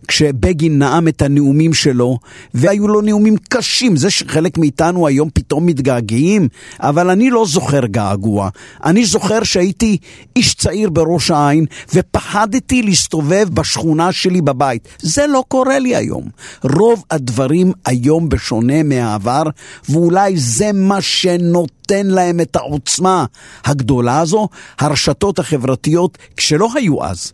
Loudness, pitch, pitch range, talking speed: -14 LUFS, 165 Hz, 140-195 Hz, 125 wpm